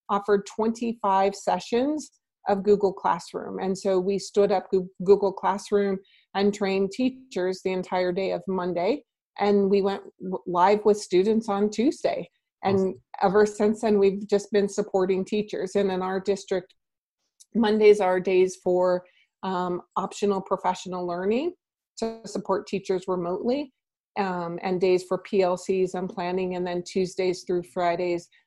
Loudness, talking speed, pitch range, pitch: -25 LUFS, 140 wpm, 185-205 Hz, 195 Hz